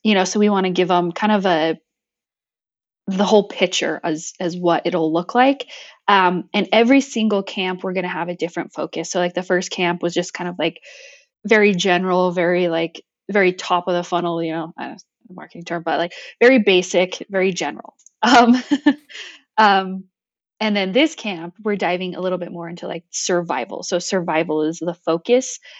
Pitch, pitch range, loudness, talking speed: 185 Hz, 175-205 Hz, -19 LUFS, 200 wpm